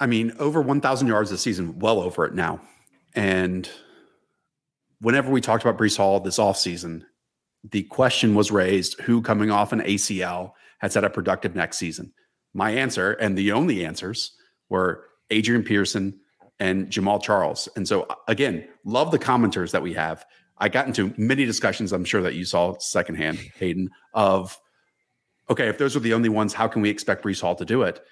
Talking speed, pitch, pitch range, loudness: 180 wpm, 105 Hz, 95-115 Hz, -23 LUFS